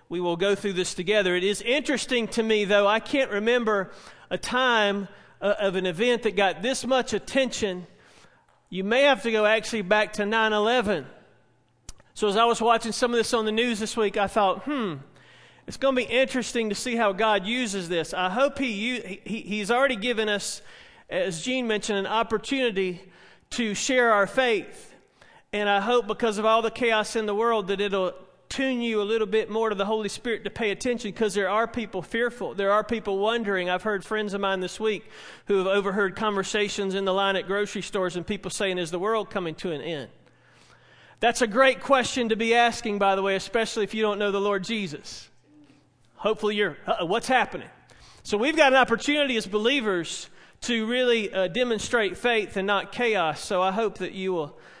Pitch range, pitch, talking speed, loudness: 195-235 Hz, 210 Hz, 205 wpm, -25 LUFS